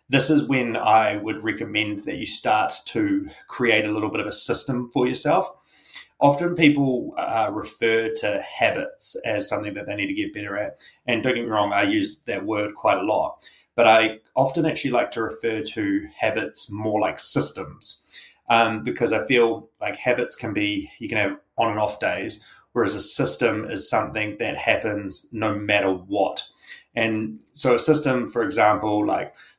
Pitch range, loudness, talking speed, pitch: 110-150 Hz, -22 LUFS, 185 wpm, 120 Hz